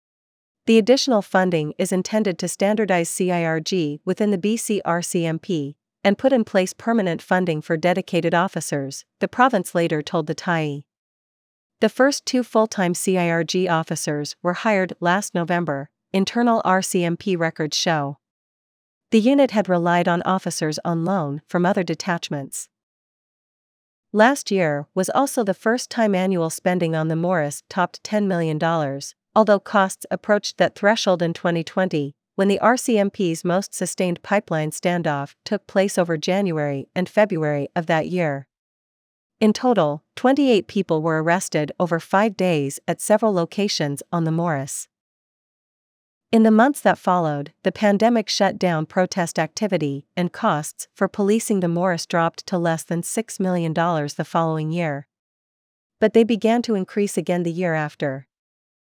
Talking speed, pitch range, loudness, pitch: 145 wpm, 165-205 Hz, -21 LUFS, 180 Hz